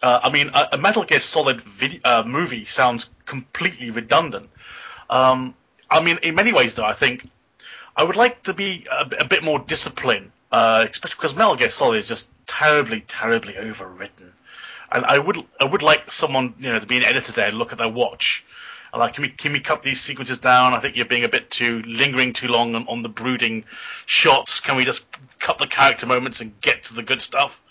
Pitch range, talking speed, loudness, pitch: 120-145 Hz, 220 wpm, -19 LUFS, 125 Hz